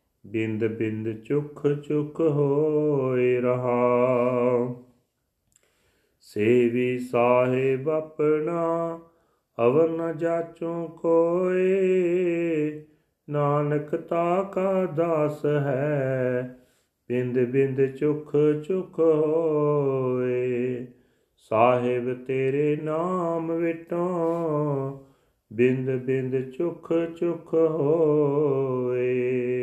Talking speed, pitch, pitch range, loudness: 65 wpm, 145 Hz, 125-165 Hz, -24 LUFS